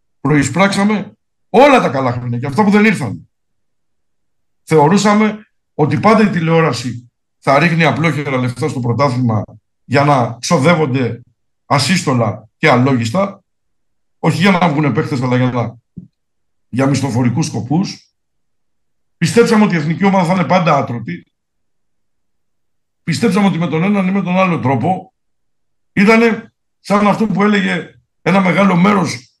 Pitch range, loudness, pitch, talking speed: 125-195 Hz, -14 LUFS, 160 Hz, 135 wpm